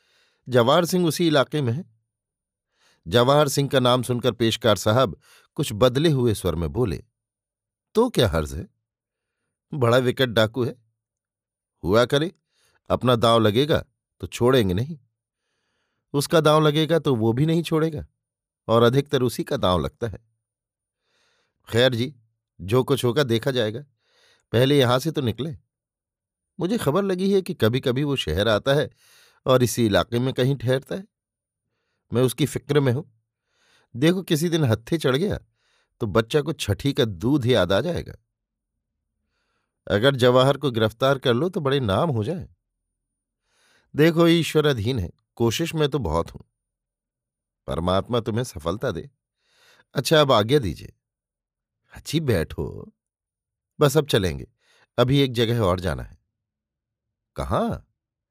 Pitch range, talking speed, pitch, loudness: 110-145 Hz, 140 wpm, 125 Hz, -22 LUFS